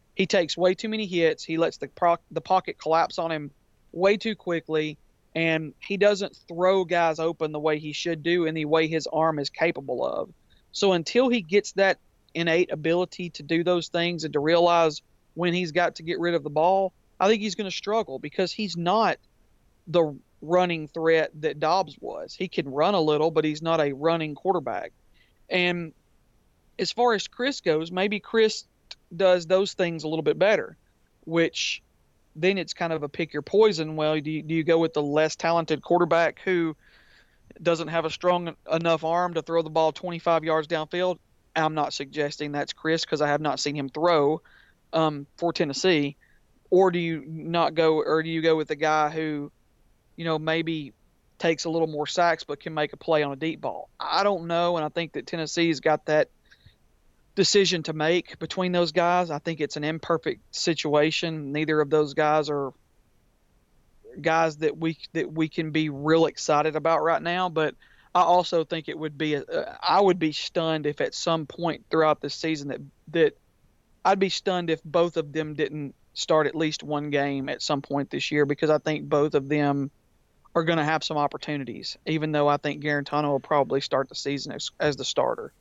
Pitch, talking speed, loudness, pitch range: 160 Hz, 200 wpm, -25 LUFS, 150-175 Hz